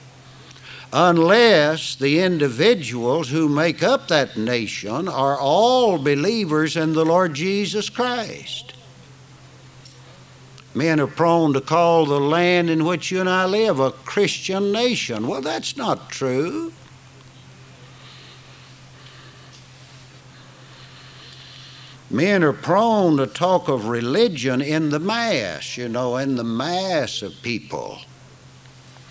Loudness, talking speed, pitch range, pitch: -20 LUFS, 110 wpm, 130-170 Hz, 135 Hz